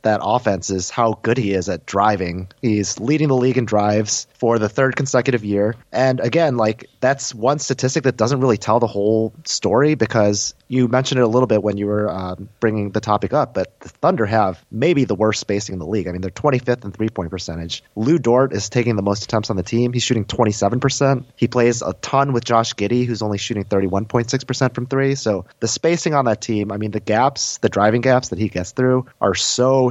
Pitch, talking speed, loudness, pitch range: 115 Hz, 225 wpm, -19 LUFS, 105-130 Hz